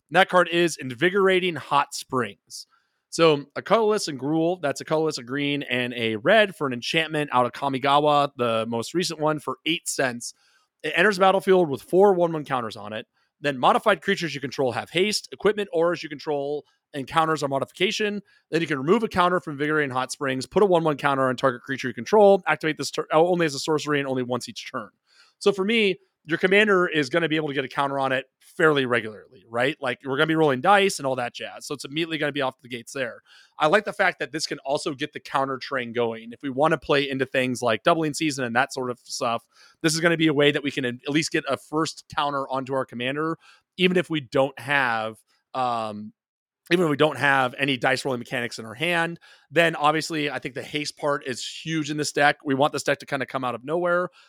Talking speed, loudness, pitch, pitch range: 240 wpm, -23 LUFS, 150 Hz, 130-165 Hz